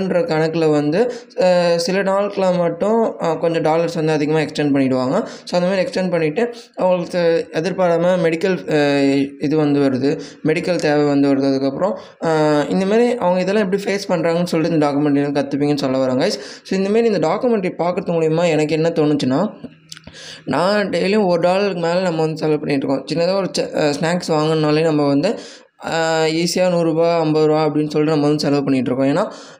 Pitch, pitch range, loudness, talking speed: 165 Hz, 150-180 Hz, -17 LUFS, 155 wpm